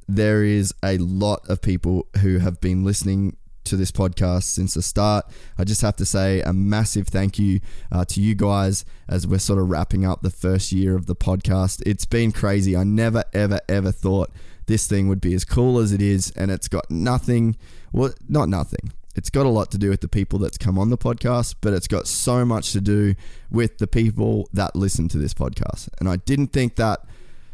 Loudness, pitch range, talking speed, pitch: -21 LUFS, 95-105 Hz, 215 wpm, 100 Hz